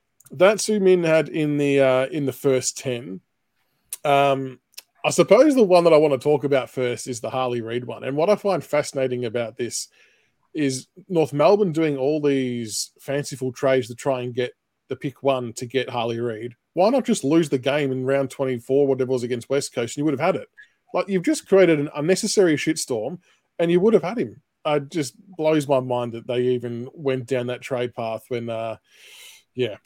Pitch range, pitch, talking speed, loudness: 125-155 Hz, 135 Hz, 210 wpm, -22 LUFS